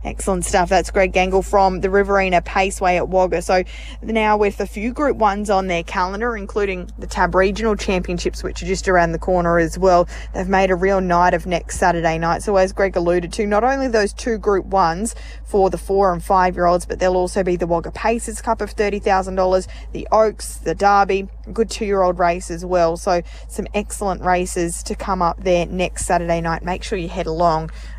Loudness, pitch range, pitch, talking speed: -18 LUFS, 175-200 Hz, 185 Hz, 215 wpm